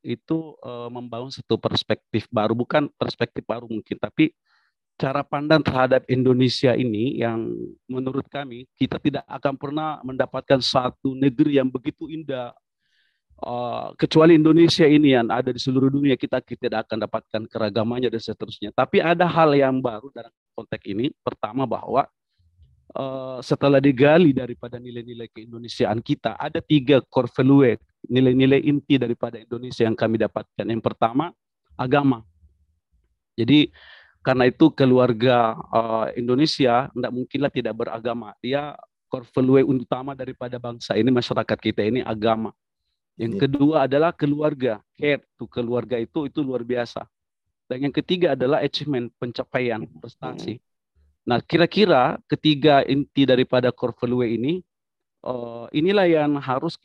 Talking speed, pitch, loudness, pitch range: 135 wpm, 125 Hz, -21 LUFS, 115-140 Hz